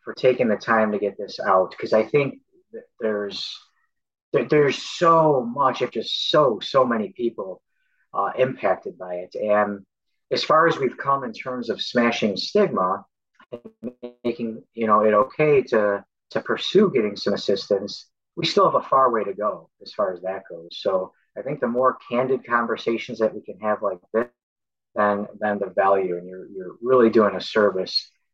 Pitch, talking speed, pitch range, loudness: 115 Hz, 185 wpm, 105-130 Hz, -22 LUFS